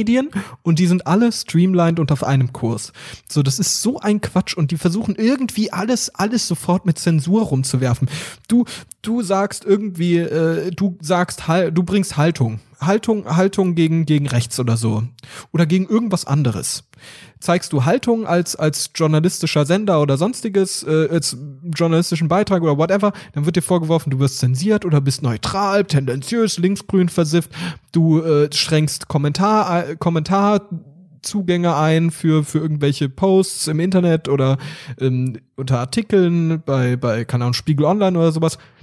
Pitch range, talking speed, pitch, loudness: 145-190 Hz, 155 wpm, 165 Hz, -18 LUFS